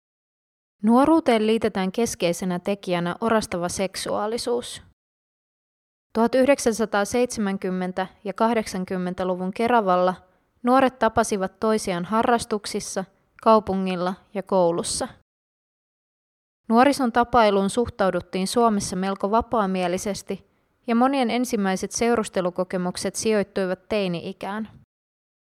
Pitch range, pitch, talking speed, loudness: 190-230 Hz, 205 Hz, 70 wpm, -23 LUFS